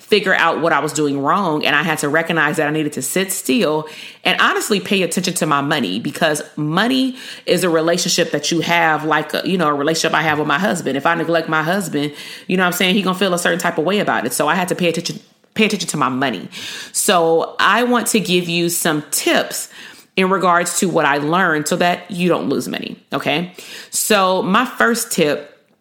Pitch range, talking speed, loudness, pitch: 155-190 Hz, 235 wpm, -17 LUFS, 170 Hz